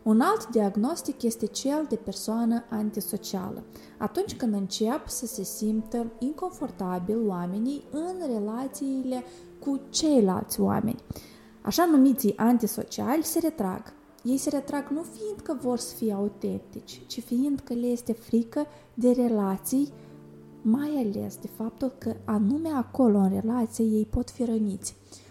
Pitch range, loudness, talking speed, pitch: 210-270 Hz, -28 LUFS, 135 wpm, 230 Hz